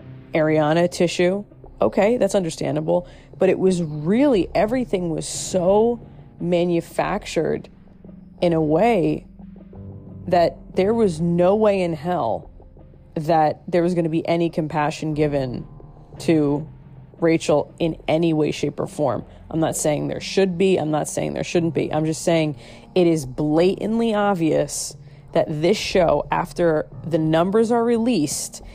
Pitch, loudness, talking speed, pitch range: 165 Hz, -21 LUFS, 140 wpm, 150-185 Hz